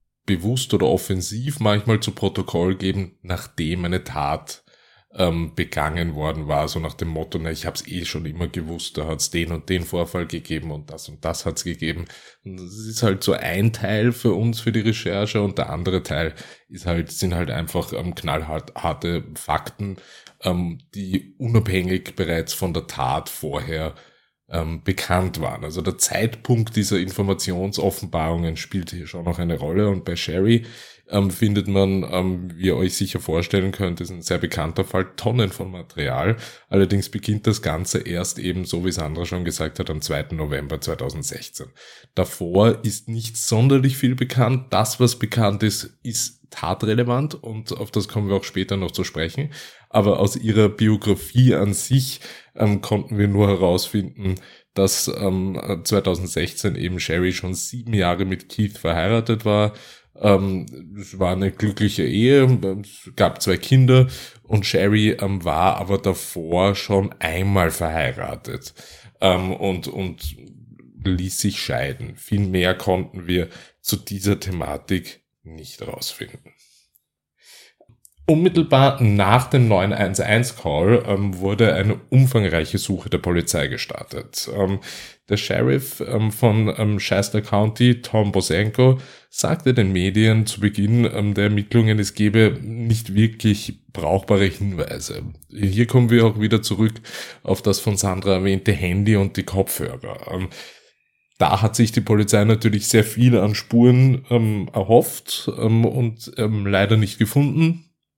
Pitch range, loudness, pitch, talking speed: 90-110 Hz, -21 LUFS, 100 Hz, 150 wpm